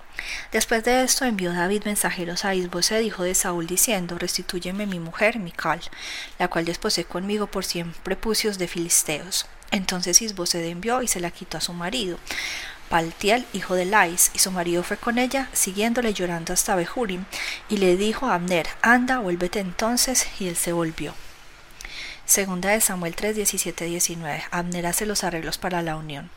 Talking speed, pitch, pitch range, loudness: 160 wpm, 185 Hz, 175-210 Hz, -23 LUFS